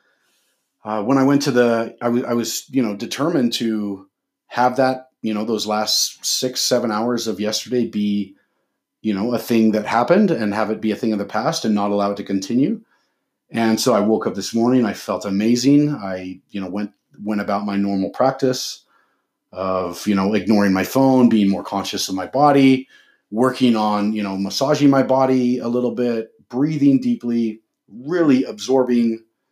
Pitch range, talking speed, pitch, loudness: 105-125 Hz, 185 wpm, 115 Hz, -19 LUFS